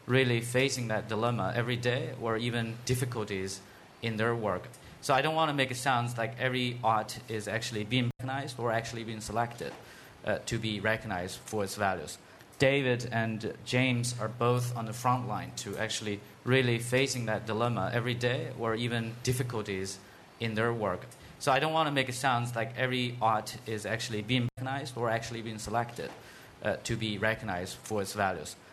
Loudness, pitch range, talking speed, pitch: -31 LUFS, 110-125 Hz, 180 wpm, 115 Hz